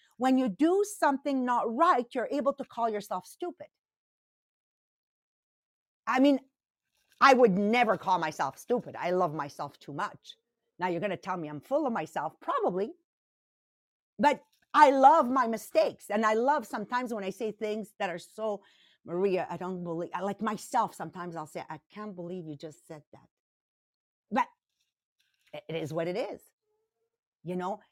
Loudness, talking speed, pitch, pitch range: -29 LUFS, 165 wpm, 215 Hz, 180-270 Hz